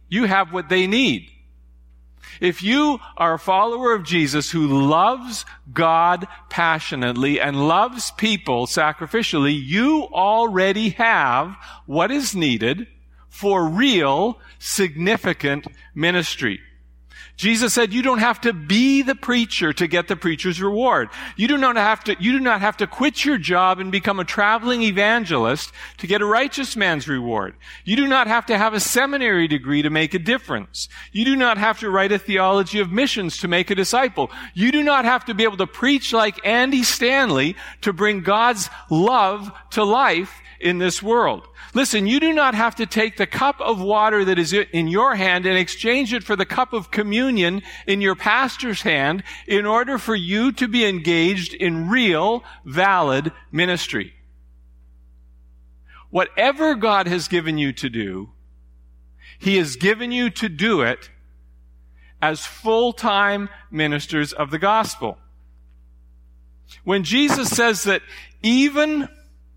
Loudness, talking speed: -19 LUFS, 155 wpm